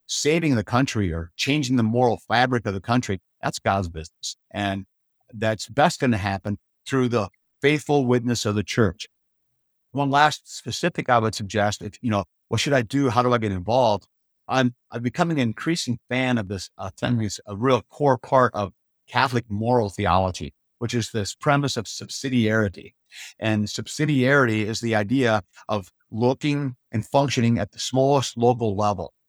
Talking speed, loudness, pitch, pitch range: 170 wpm, -23 LUFS, 120 Hz, 105-130 Hz